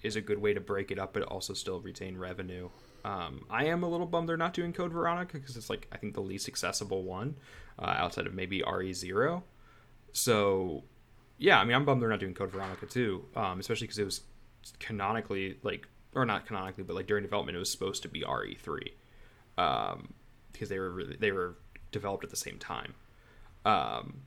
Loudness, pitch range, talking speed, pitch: -33 LUFS, 95-125 Hz, 205 wpm, 105 Hz